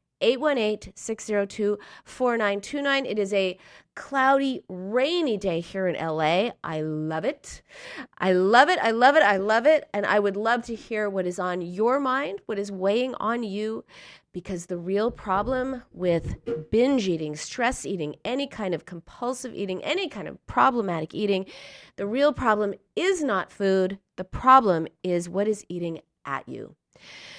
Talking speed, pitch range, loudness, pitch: 160 wpm, 185-245 Hz, -25 LUFS, 205 Hz